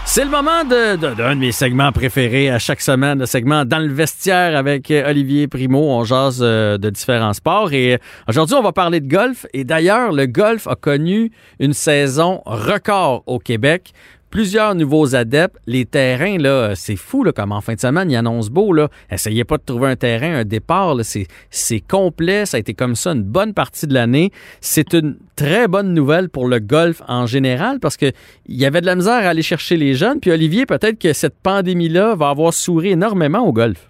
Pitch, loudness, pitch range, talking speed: 145 Hz, -16 LUFS, 125-175 Hz, 210 wpm